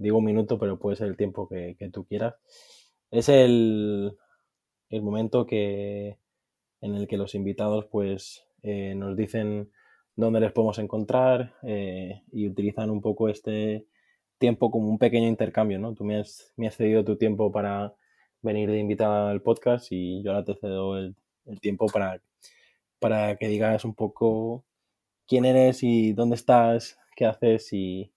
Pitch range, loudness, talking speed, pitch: 100-115 Hz, -26 LUFS, 165 wpm, 105 Hz